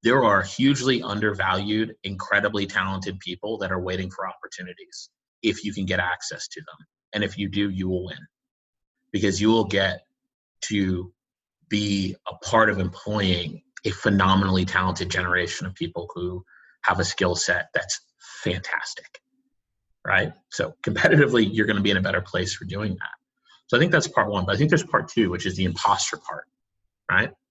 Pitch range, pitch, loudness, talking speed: 95-105 Hz, 95 Hz, -24 LUFS, 175 wpm